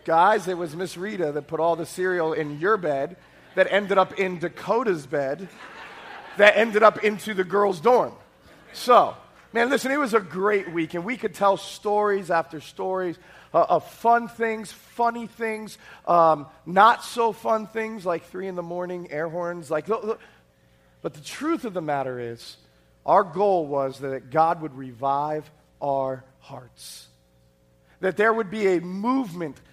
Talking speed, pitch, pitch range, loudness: 170 wpm, 180 Hz, 150-210 Hz, -23 LUFS